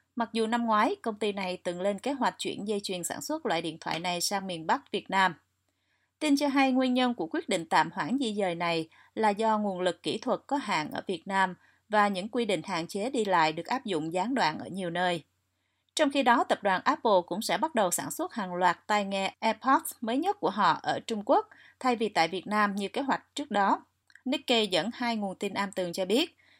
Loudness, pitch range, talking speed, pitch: -29 LUFS, 180-250 Hz, 245 wpm, 210 Hz